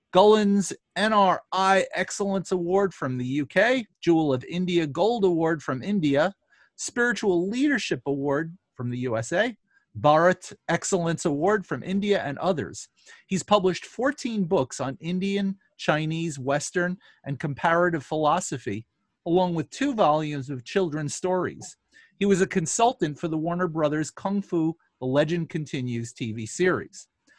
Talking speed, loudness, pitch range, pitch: 130 wpm, -25 LUFS, 150-195 Hz, 175 Hz